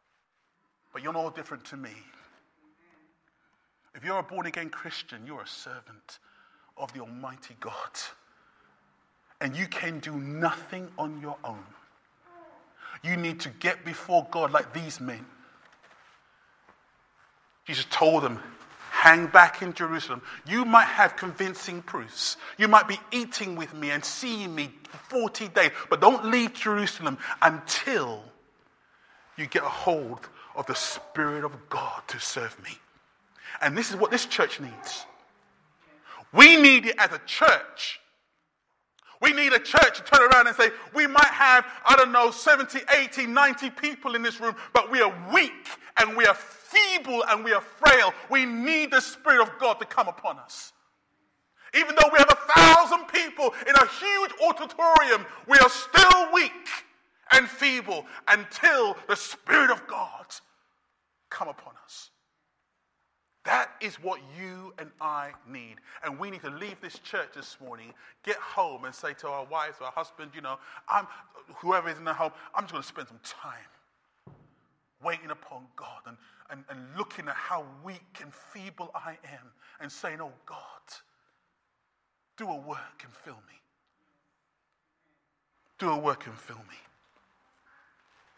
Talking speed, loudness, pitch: 155 wpm, -21 LUFS, 215 Hz